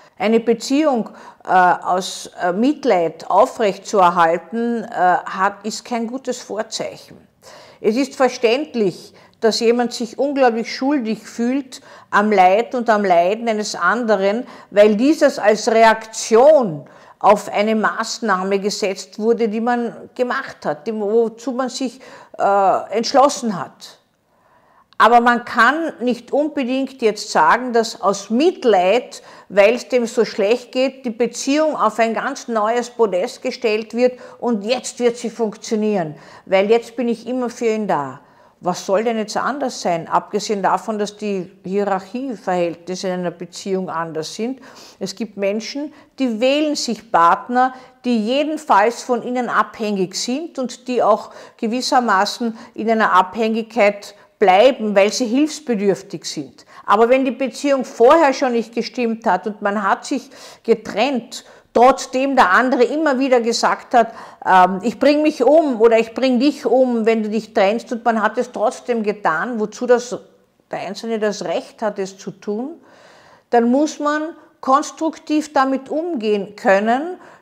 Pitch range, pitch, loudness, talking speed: 205-255 Hz, 230 Hz, -18 LUFS, 145 wpm